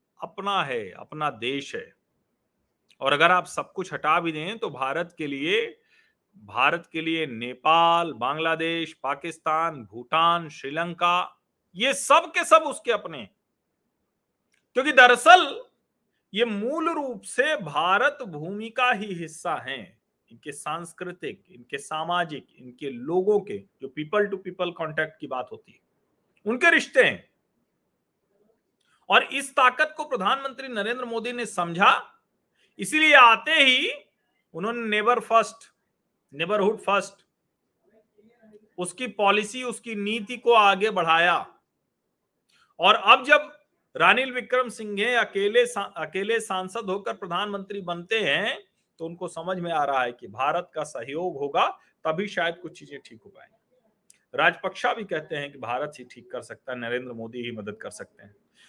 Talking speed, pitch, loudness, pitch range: 145 wpm, 200 Hz, -23 LUFS, 165-240 Hz